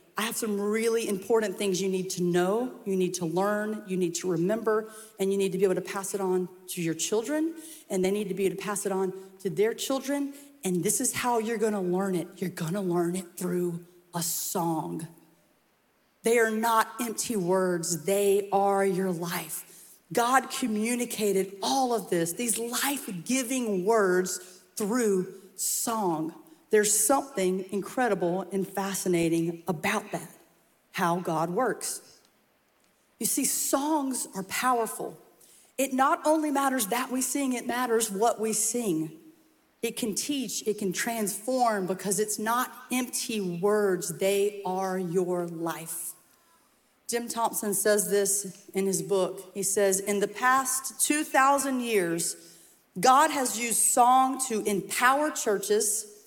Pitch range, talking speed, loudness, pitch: 185-240 Hz, 150 wpm, -27 LUFS, 205 Hz